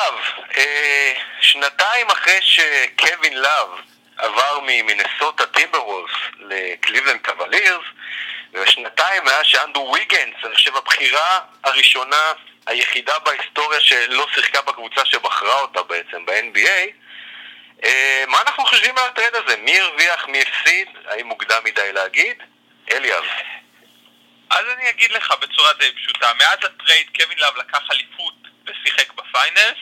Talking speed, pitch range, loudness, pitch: 115 wpm, 225-280 Hz, -15 LUFS, 240 Hz